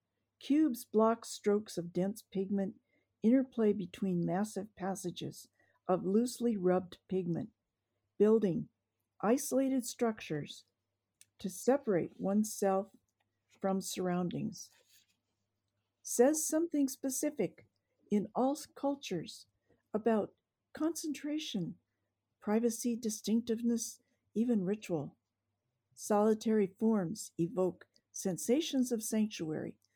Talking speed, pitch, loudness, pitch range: 80 wpm, 210 Hz, -34 LUFS, 175-235 Hz